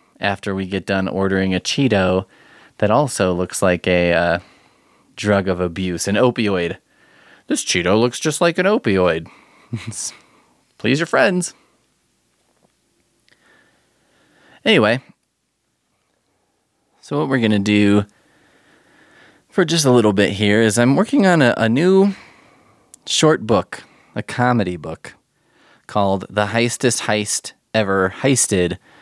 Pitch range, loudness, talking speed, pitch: 95-125 Hz, -17 LUFS, 120 wpm, 105 Hz